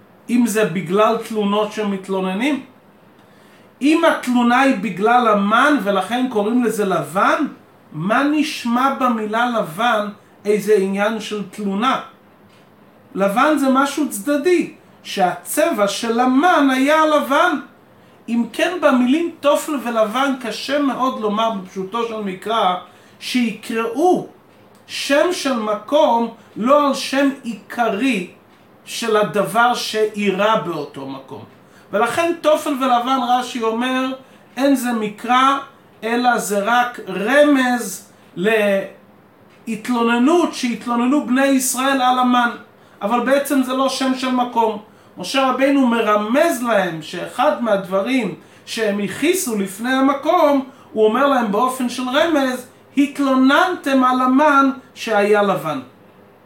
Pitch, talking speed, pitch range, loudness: 245 Hz, 105 wpm, 210-275 Hz, -17 LUFS